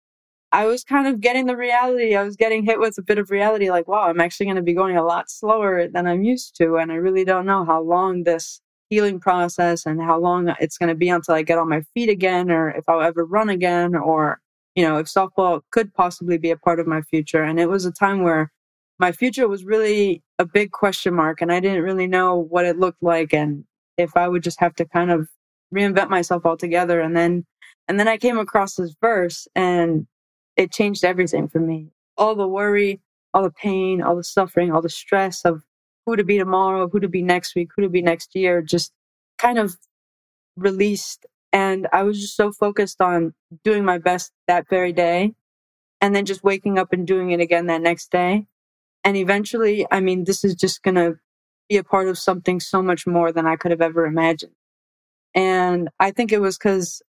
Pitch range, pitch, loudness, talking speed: 170-200 Hz, 180 Hz, -20 LUFS, 220 wpm